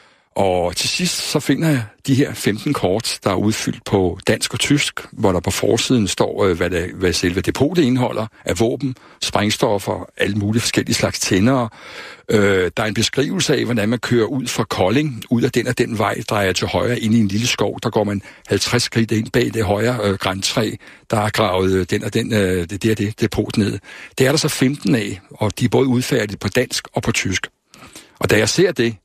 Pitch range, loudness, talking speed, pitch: 100-125 Hz, -18 LUFS, 215 wpm, 110 Hz